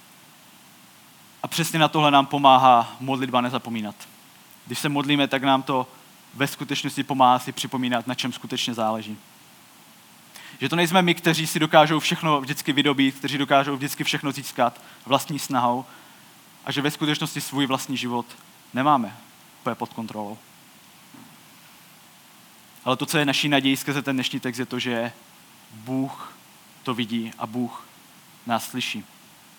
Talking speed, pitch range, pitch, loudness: 145 wpm, 125-145 Hz, 135 Hz, -23 LUFS